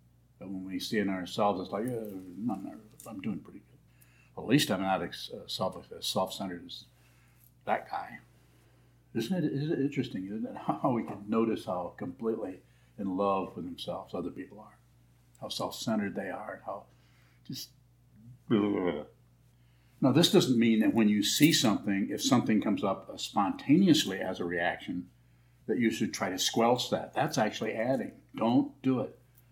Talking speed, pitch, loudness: 175 wpm, 100 Hz, -31 LUFS